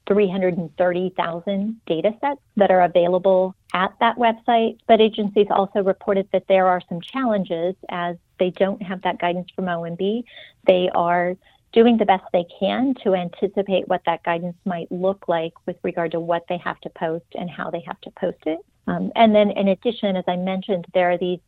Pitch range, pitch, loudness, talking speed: 175-205 Hz, 185 Hz, -21 LUFS, 185 wpm